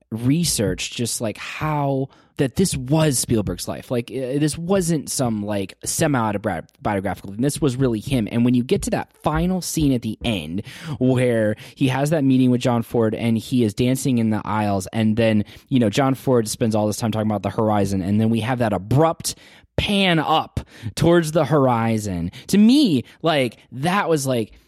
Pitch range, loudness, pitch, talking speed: 110-145 Hz, -20 LUFS, 125 Hz, 185 wpm